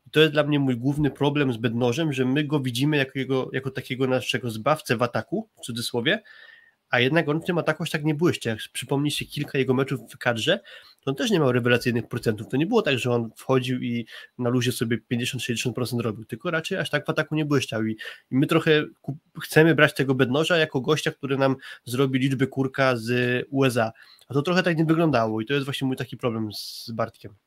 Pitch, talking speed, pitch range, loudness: 135 Hz, 220 wpm, 125-150 Hz, -24 LUFS